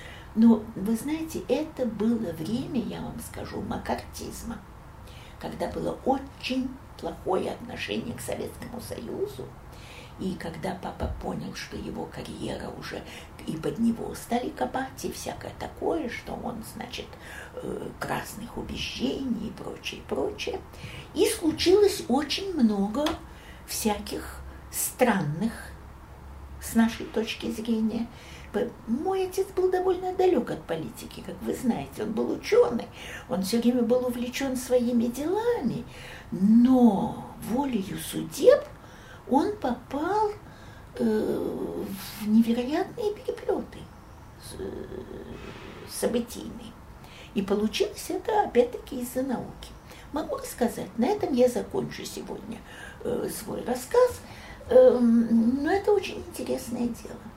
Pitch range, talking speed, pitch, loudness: 225-370 Hz, 105 wpm, 250 Hz, -28 LUFS